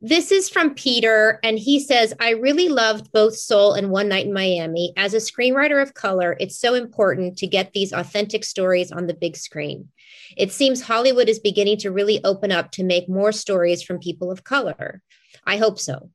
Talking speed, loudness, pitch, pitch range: 200 wpm, -19 LUFS, 205 Hz, 185-230 Hz